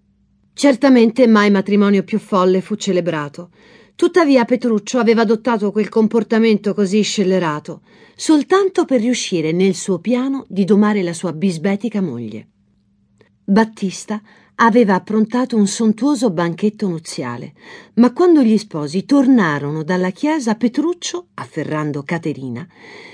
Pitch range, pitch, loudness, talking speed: 180-240 Hz, 210 Hz, -16 LUFS, 115 wpm